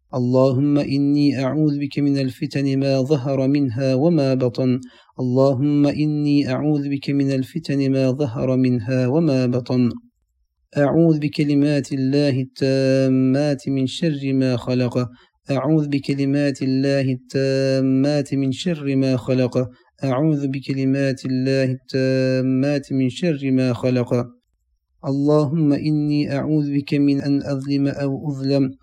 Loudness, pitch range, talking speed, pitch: -20 LUFS, 130-145 Hz, 115 wpm, 135 Hz